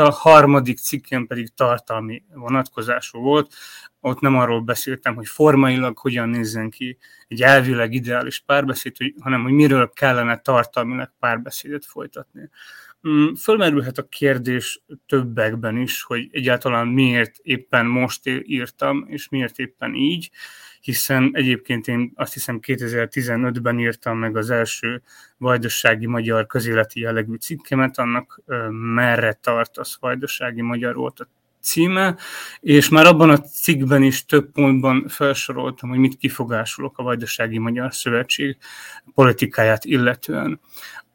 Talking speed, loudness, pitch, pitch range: 120 wpm, -19 LUFS, 125 Hz, 120-135 Hz